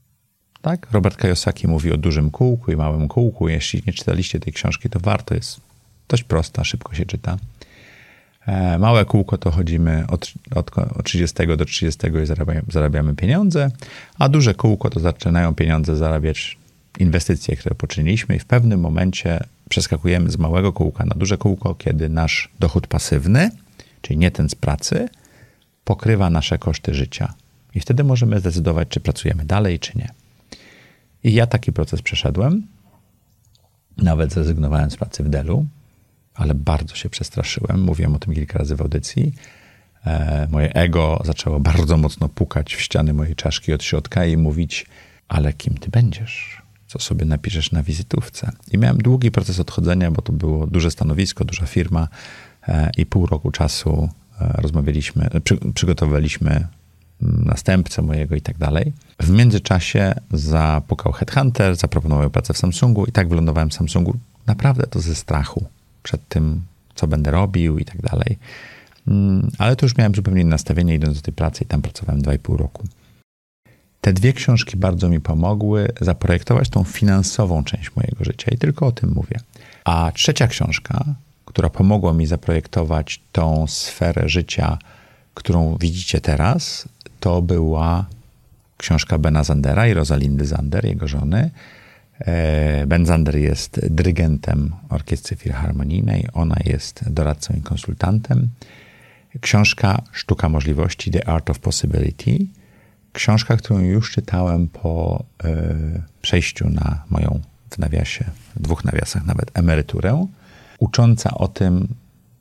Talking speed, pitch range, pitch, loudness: 140 wpm, 80-110 Hz, 90 Hz, -19 LUFS